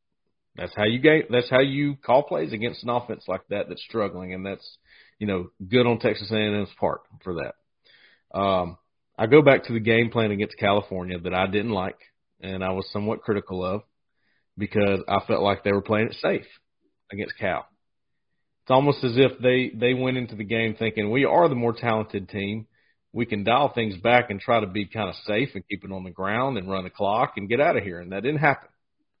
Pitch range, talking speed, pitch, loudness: 100-120 Hz, 220 wpm, 110 Hz, -24 LUFS